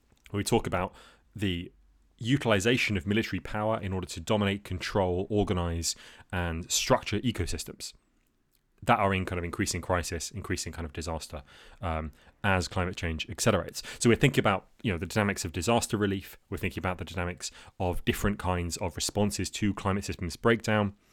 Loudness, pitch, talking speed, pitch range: -30 LUFS, 95 Hz, 170 wpm, 85-105 Hz